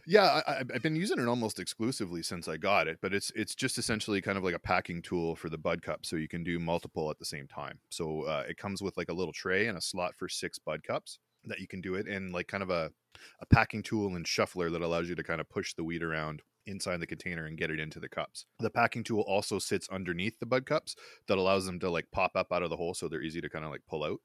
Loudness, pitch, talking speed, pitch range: -33 LUFS, 90 Hz, 285 wpm, 85-110 Hz